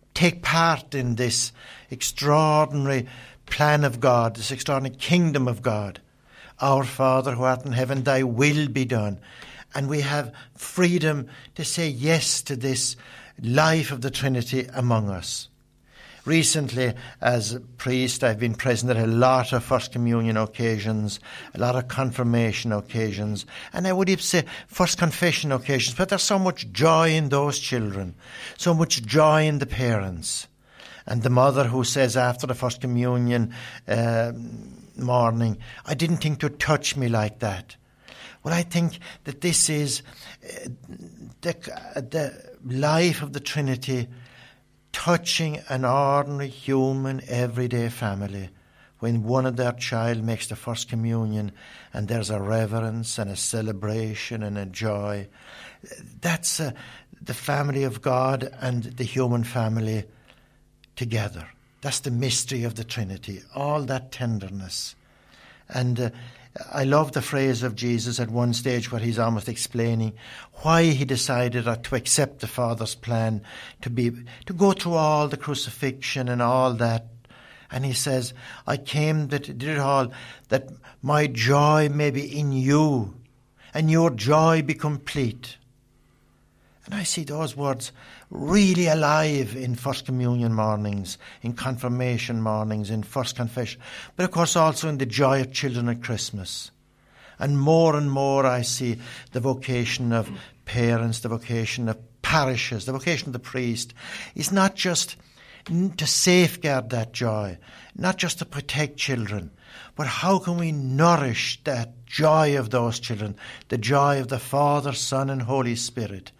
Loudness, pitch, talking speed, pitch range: -24 LUFS, 130 Hz, 150 wpm, 115-145 Hz